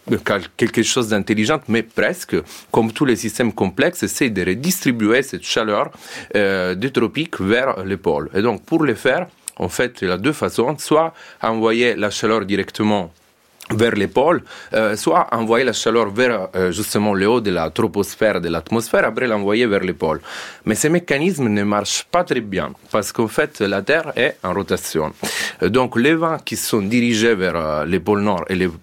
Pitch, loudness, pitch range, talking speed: 110 Hz, -18 LUFS, 100-125 Hz, 195 wpm